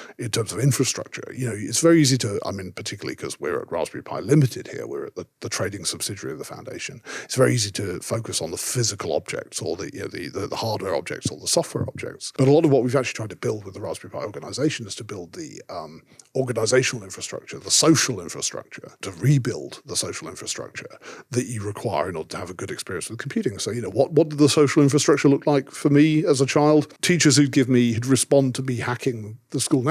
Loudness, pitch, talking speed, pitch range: -22 LUFS, 135 Hz, 245 wpm, 120-150 Hz